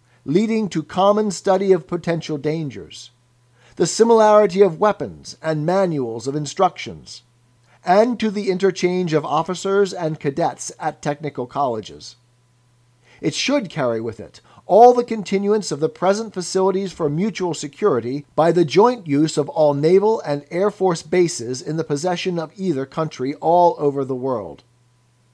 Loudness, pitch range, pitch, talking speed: -19 LUFS, 135-190 Hz, 160 Hz, 145 wpm